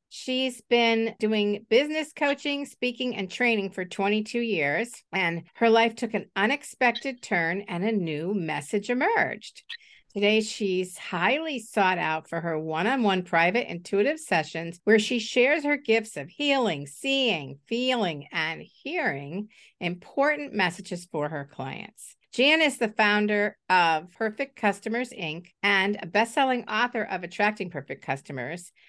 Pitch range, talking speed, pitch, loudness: 175-245 Hz, 145 wpm, 210 Hz, -26 LUFS